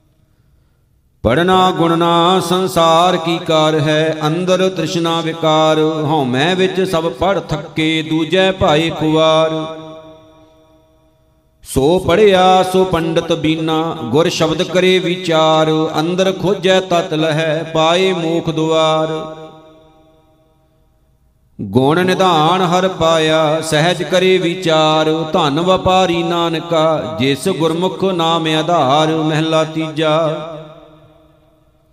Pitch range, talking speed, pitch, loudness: 155-175 Hz, 90 wpm, 160 Hz, -14 LUFS